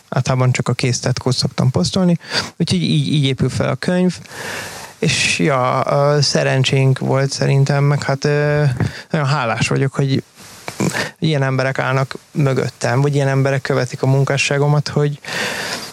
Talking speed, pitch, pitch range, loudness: 140 wpm, 140 Hz, 135-145 Hz, -17 LUFS